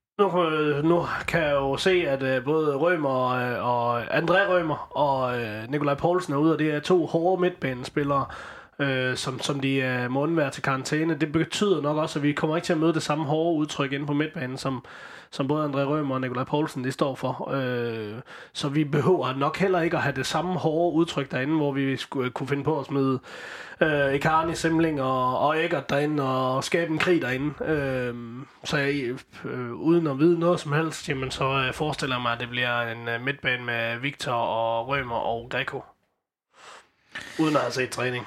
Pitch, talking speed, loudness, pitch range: 140 Hz, 200 wpm, -25 LUFS, 130-160 Hz